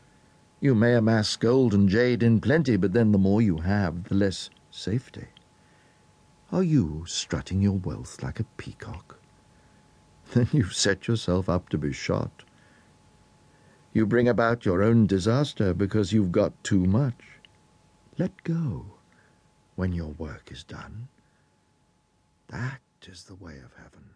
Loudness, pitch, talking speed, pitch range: -25 LUFS, 105 Hz, 140 wpm, 90-120 Hz